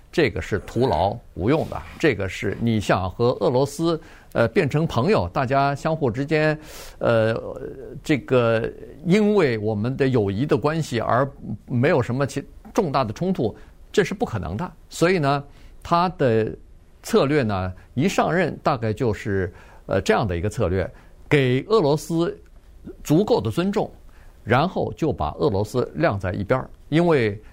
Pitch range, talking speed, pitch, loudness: 110-155 Hz, 225 characters per minute, 135 Hz, -22 LUFS